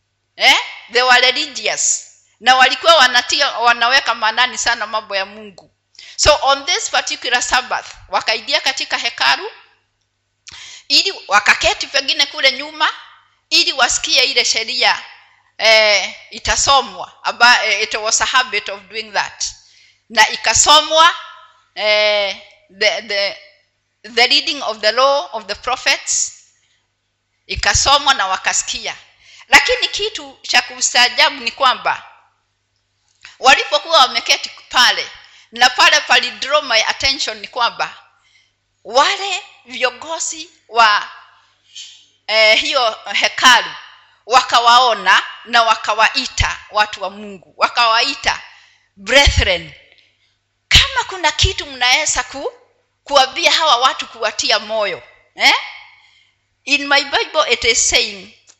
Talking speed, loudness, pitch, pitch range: 95 wpm, -13 LUFS, 255 Hz, 220-305 Hz